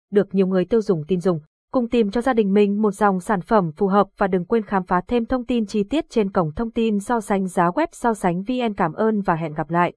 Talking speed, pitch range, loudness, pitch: 275 wpm, 185-230 Hz, -21 LUFS, 205 Hz